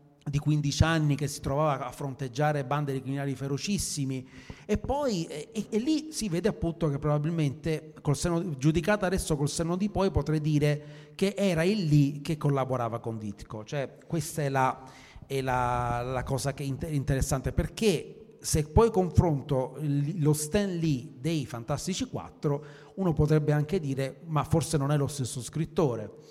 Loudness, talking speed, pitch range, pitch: -29 LUFS, 165 wpm, 135-165 Hz, 150 Hz